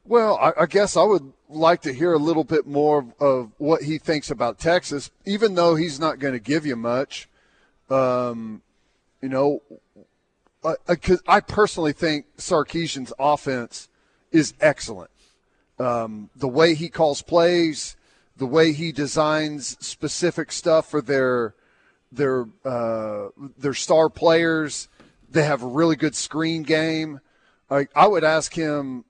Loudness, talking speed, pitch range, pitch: -21 LUFS, 150 wpm, 135-165 Hz, 150 Hz